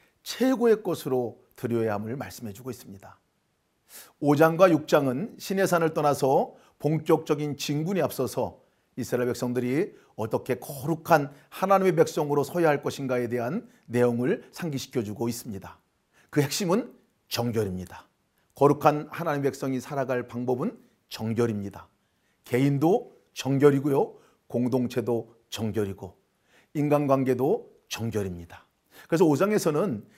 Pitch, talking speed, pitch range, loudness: 130 Hz, 295 characters per minute, 120-155 Hz, -26 LUFS